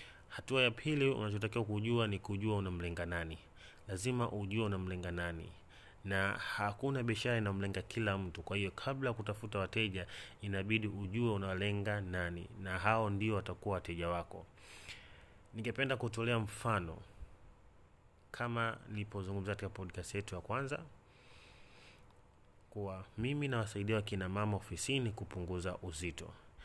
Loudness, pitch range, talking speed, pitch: -38 LUFS, 90-110 Hz, 115 wpm, 100 Hz